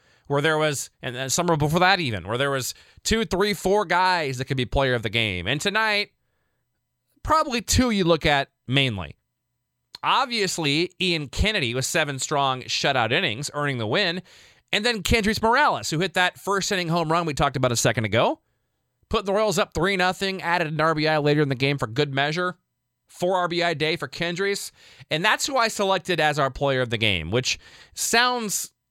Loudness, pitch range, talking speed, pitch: -23 LUFS, 135-190 Hz, 195 wpm, 160 Hz